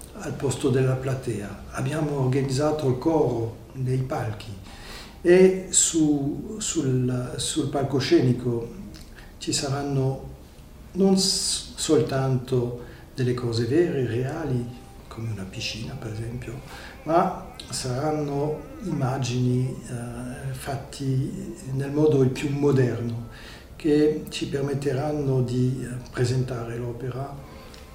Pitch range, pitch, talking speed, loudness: 120-145 Hz, 130 Hz, 95 wpm, -25 LUFS